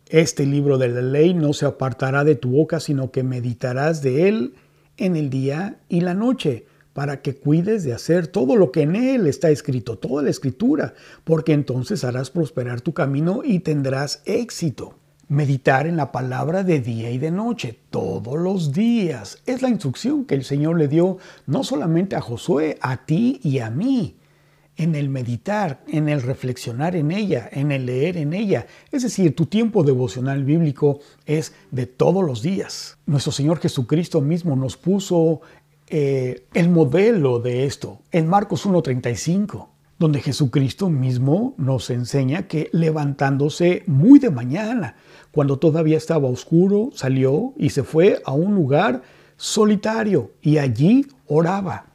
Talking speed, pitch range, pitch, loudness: 160 wpm, 135-175 Hz, 155 Hz, -20 LUFS